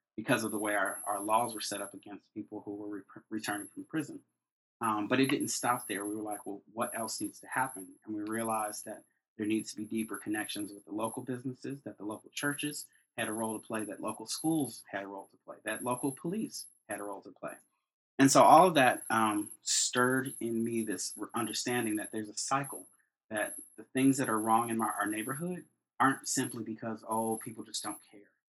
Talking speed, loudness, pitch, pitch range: 220 wpm, -32 LUFS, 110 Hz, 105-130 Hz